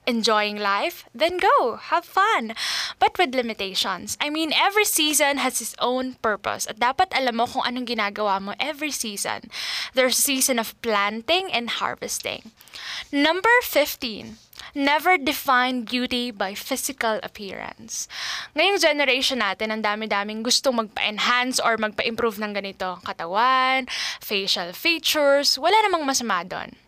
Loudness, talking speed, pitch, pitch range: -22 LUFS, 135 wpm, 250 Hz, 220-300 Hz